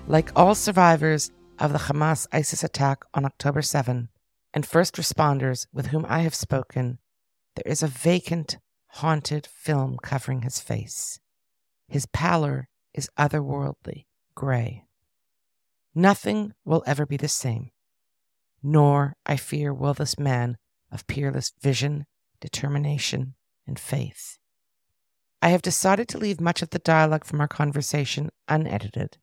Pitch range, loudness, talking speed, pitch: 125-155 Hz, -24 LUFS, 130 wpm, 145 Hz